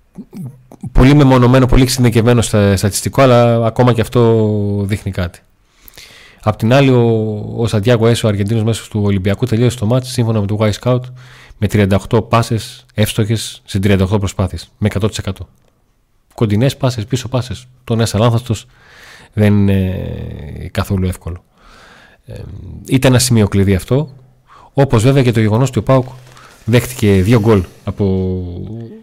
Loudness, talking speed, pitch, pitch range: -14 LUFS, 145 wpm, 110 Hz, 100-125 Hz